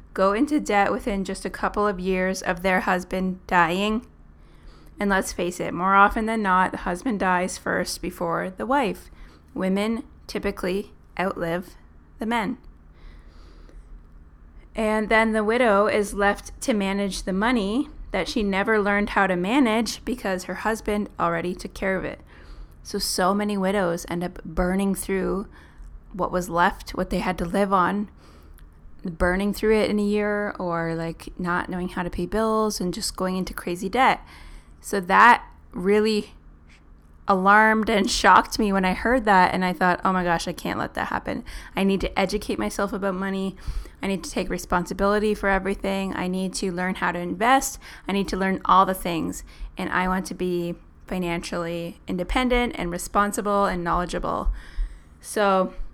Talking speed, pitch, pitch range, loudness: 170 wpm, 190 Hz, 175-205 Hz, -23 LUFS